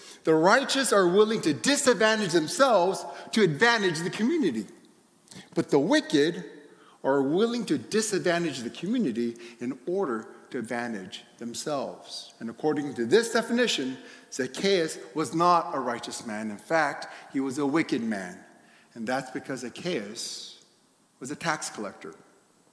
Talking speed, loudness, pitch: 135 wpm, -26 LUFS, 175 Hz